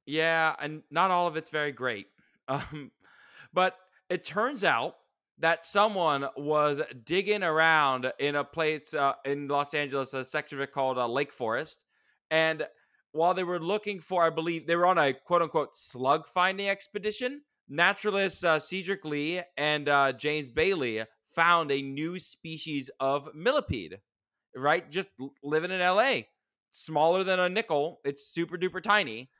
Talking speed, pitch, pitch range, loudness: 155 wpm, 160 Hz, 145-180 Hz, -28 LUFS